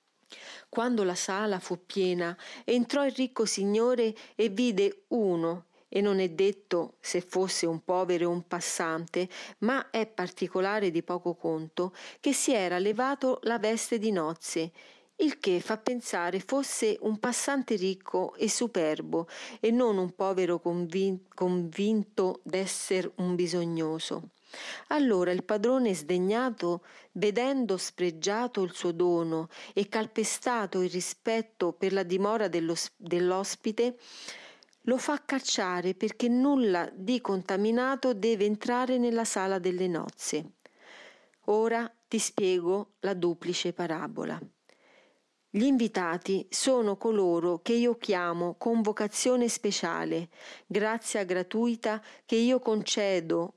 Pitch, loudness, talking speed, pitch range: 200 Hz, -29 LUFS, 120 wpm, 180-230 Hz